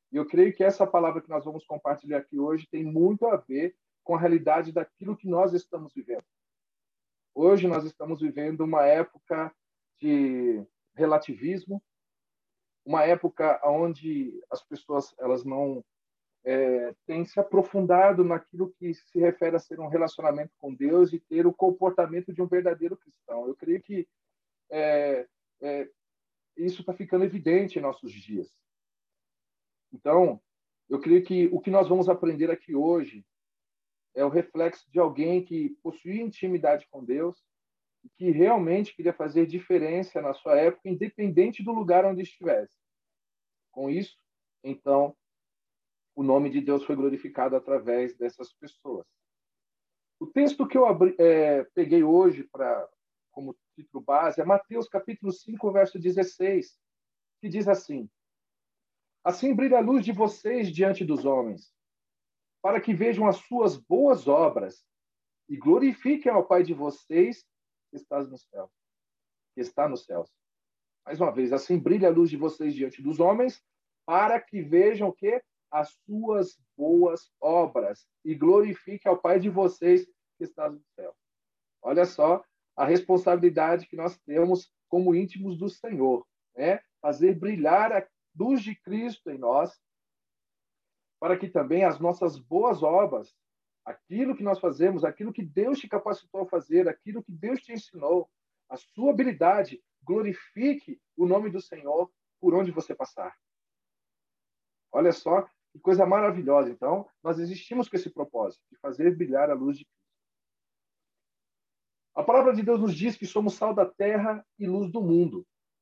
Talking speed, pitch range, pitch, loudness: 150 wpm, 155-205 Hz, 180 Hz, -26 LUFS